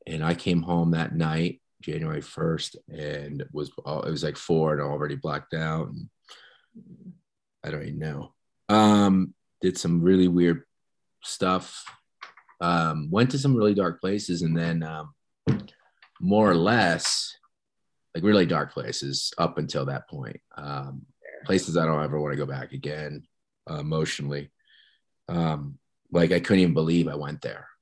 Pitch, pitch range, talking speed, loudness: 80 Hz, 75-90 Hz, 155 wpm, -26 LUFS